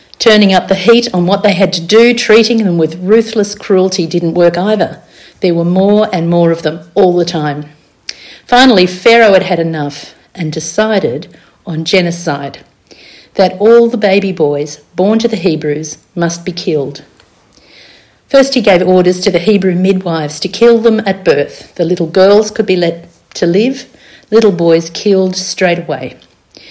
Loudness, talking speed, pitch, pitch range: -10 LUFS, 170 wpm, 185 Hz, 170-210 Hz